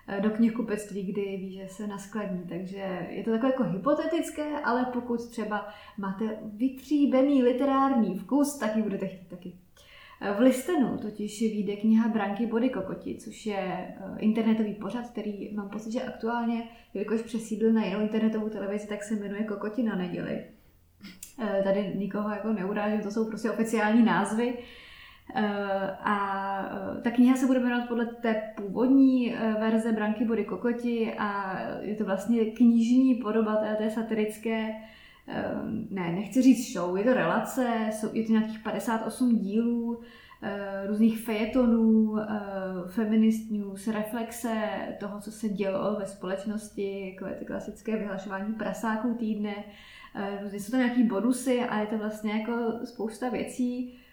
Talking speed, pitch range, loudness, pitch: 140 wpm, 205-235 Hz, -28 LUFS, 220 Hz